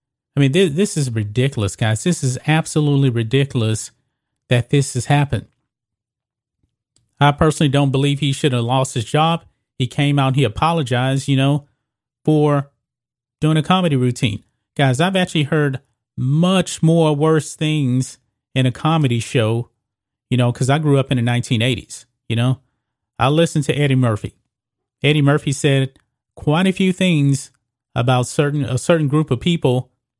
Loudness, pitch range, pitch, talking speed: -18 LUFS, 125-150 Hz, 135 Hz, 160 wpm